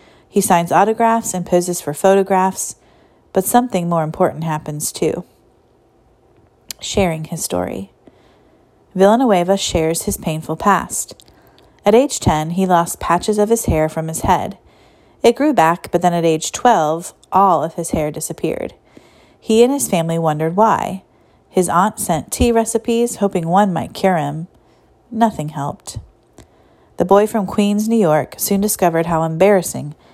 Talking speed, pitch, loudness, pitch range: 145 wpm, 185 Hz, -16 LUFS, 160-210 Hz